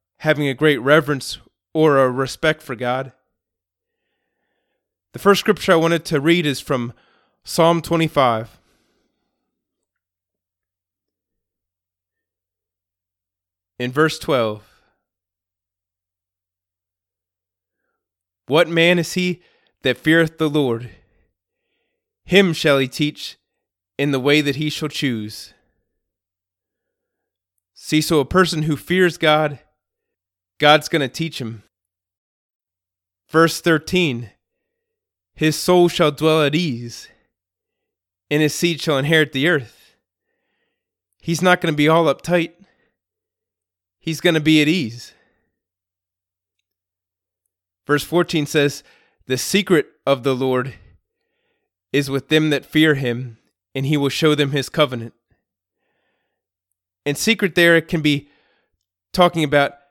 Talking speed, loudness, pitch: 110 wpm, -18 LUFS, 135 Hz